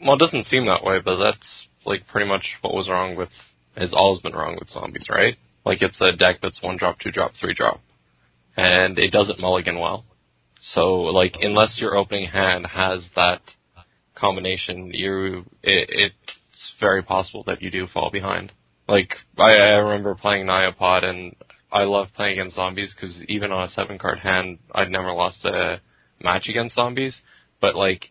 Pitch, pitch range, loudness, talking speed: 95 Hz, 90-100 Hz, -20 LUFS, 180 wpm